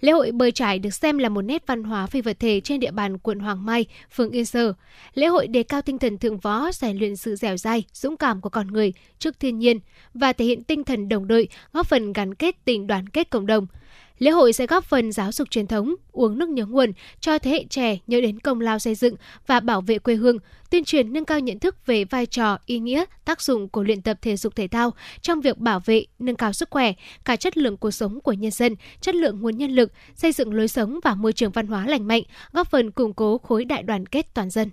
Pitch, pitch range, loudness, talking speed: 235 Hz, 220-275 Hz, -22 LUFS, 260 wpm